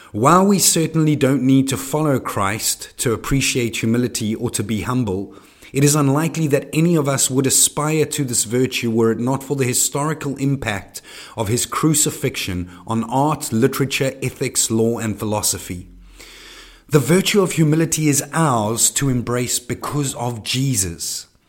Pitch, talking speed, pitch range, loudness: 130 Hz, 155 wpm, 115-145 Hz, -18 LUFS